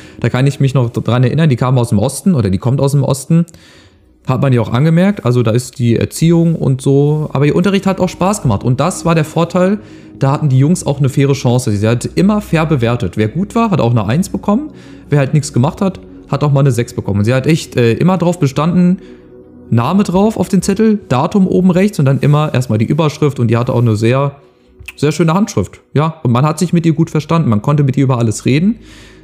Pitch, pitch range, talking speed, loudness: 140 Hz, 120-170 Hz, 250 wpm, -13 LUFS